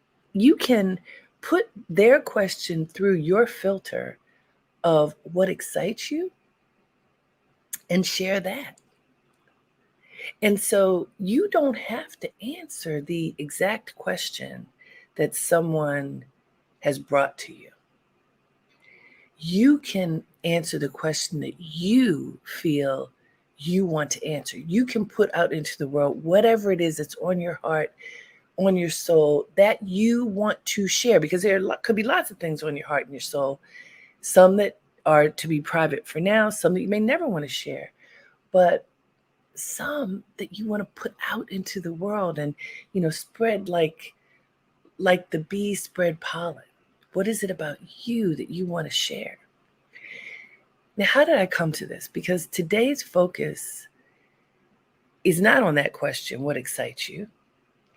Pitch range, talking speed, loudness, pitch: 160-215 Hz, 150 wpm, -24 LUFS, 185 Hz